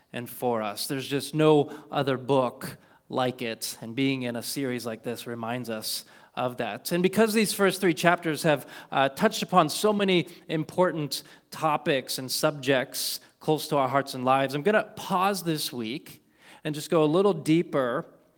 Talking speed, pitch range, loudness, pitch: 175 wpm, 125-170 Hz, -26 LUFS, 145 Hz